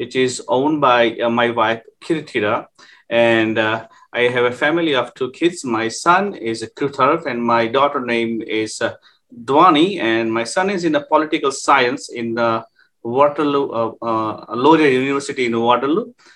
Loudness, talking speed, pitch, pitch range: -17 LUFS, 165 wpm, 120 Hz, 115-140 Hz